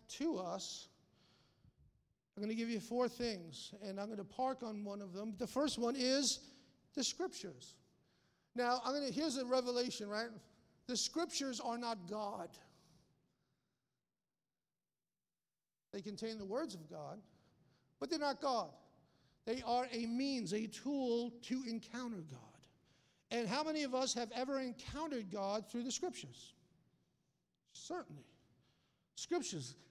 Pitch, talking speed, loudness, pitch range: 240 Hz, 135 wpm, -41 LUFS, 210-265 Hz